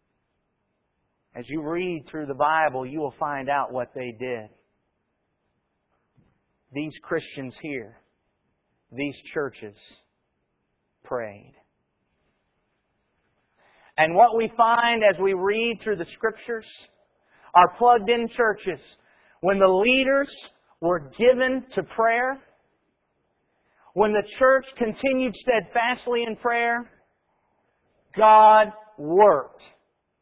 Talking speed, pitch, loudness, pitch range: 95 wpm, 210 Hz, -22 LUFS, 155-235 Hz